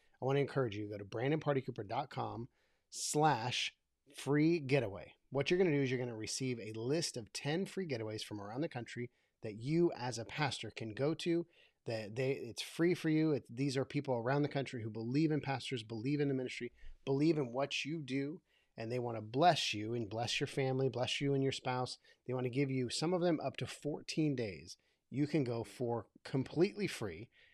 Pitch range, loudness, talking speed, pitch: 120-150 Hz, -37 LUFS, 215 wpm, 135 Hz